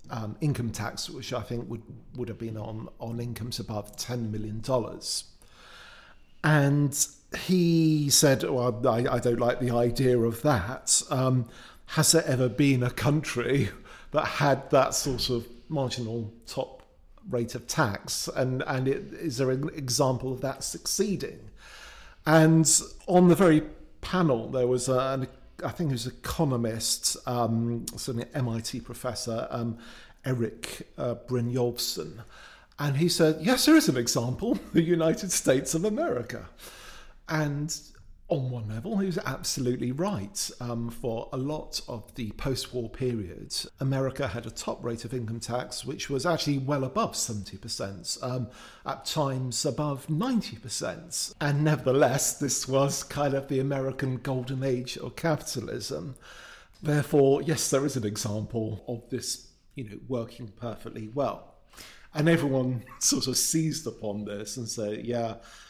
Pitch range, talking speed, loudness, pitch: 120-145 Hz, 150 wpm, -28 LUFS, 130 Hz